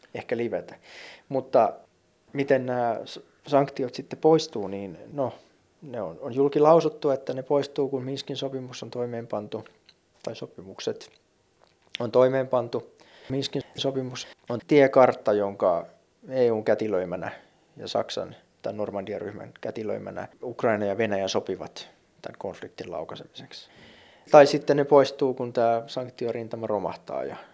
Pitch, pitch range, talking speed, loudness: 130 Hz, 115-140 Hz, 120 wpm, -26 LUFS